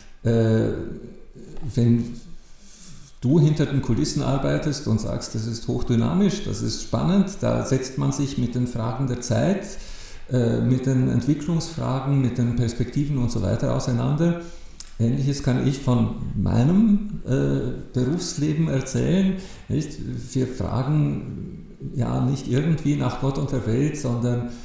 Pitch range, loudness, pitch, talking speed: 120-150 Hz, -23 LUFS, 130 Hz, 125 wpm